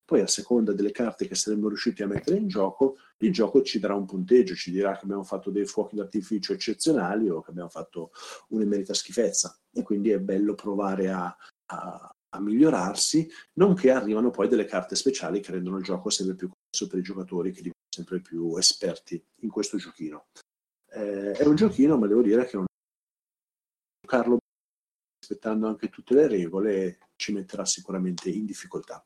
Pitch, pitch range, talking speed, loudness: 100 Hz, 95-110 Hz, 180 wpm, -26 LUFS